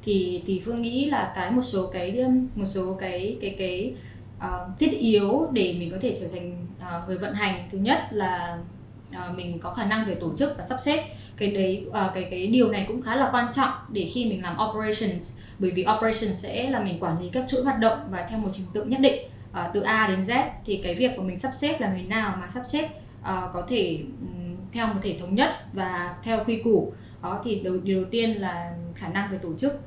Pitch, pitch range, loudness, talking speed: 205 Hz, 185-235 Hz, -26 LUFS, 235 wpm